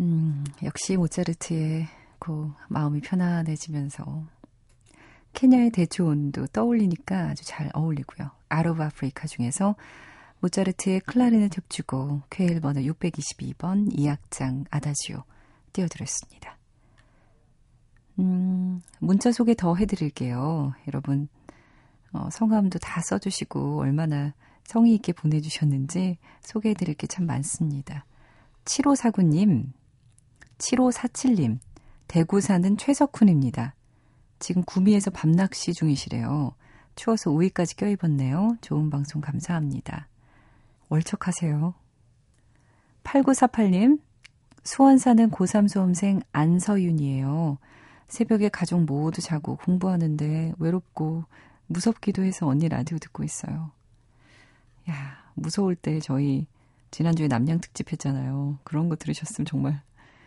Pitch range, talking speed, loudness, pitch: 140-185 Hz, 255 characters per minute, -25 LUFS, 160 Hz